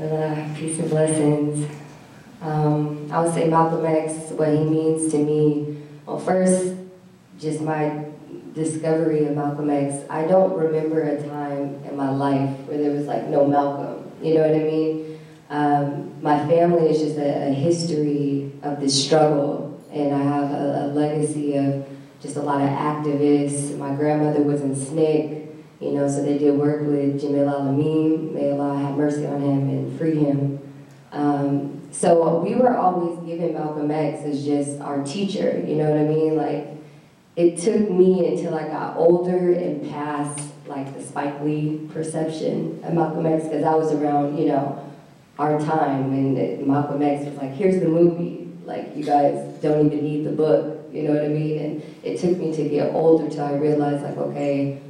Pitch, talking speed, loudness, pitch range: 150 Hz, 180 wpm, -22 LUFS, 145-155 Hz